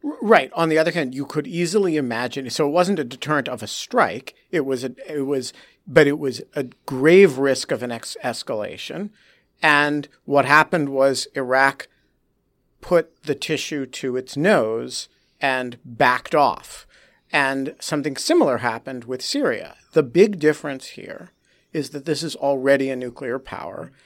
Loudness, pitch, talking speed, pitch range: -21 LUFS, 140 Hz, 160 wpm, 130-155 Hz